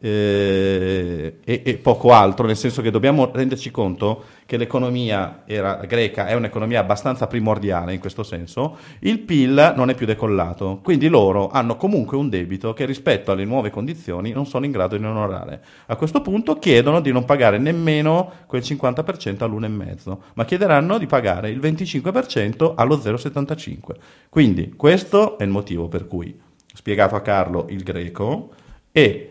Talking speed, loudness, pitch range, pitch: 160 wpm, -19 LUFS, 100-140 Hz, 115 Hz